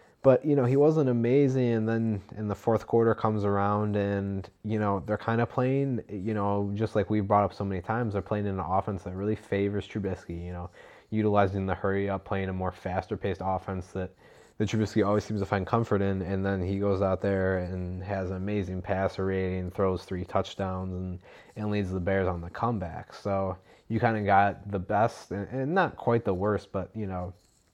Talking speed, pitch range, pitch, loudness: 215 wpm, 95-110 Hz, 100 Hz, -29 LUFS